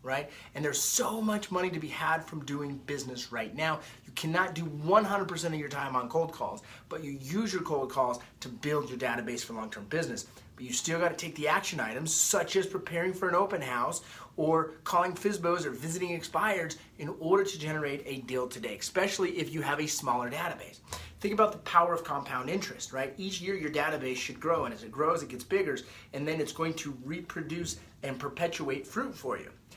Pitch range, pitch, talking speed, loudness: 140-175 Hz, 160 Hz, 210 wpm, -32 LUFS